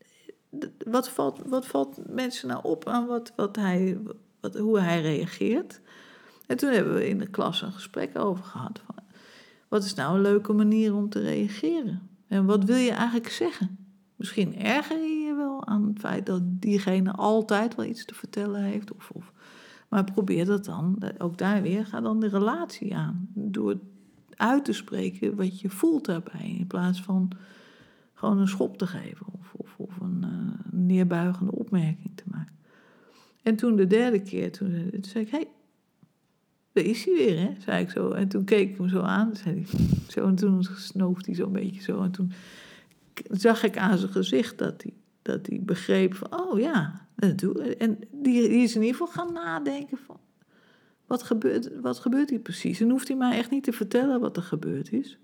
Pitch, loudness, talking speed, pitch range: 205 Hz, -27 LUFS, 190 wpm, 185-230 Hz